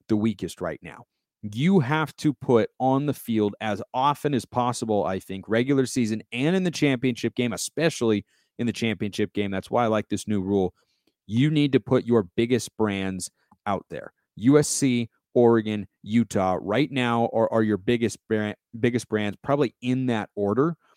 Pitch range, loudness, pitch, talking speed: 105-130 Hz, -25 LUFS, 115 Hz, 170 wpm